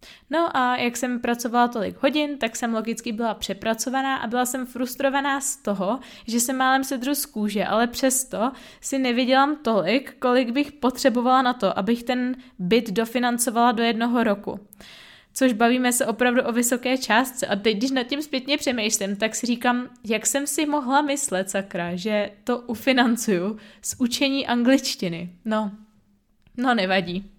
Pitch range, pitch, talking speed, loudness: 215-265 Hz, 245 Hz, 160 wpm, -23 LUFS